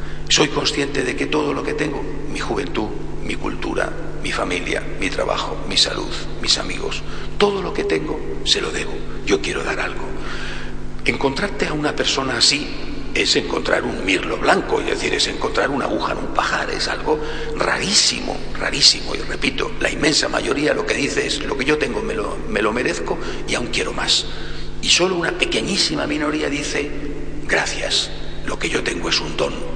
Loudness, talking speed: -20 LUFS, 180 wpm